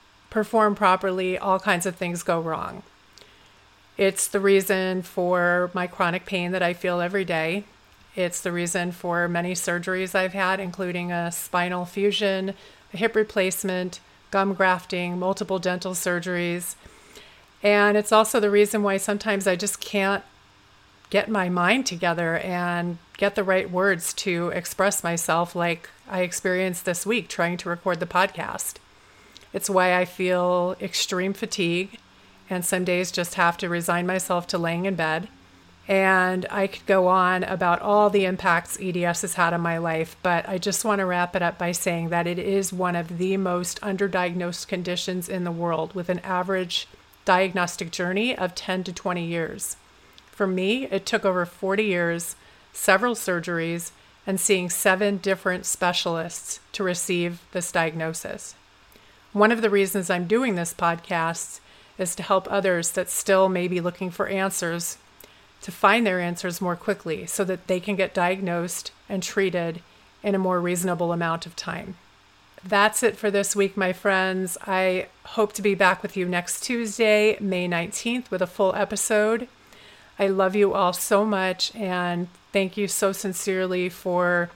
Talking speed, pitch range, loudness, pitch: 160 wpm, 175-195 Hz, -24 LUFS, 185 Hz